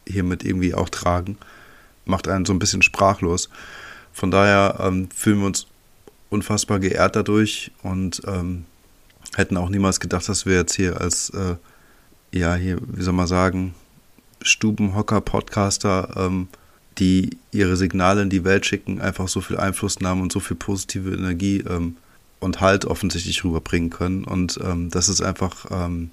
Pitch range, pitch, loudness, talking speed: 90-100 Hz, 95 Hz, -21 LUFS, 160 wpm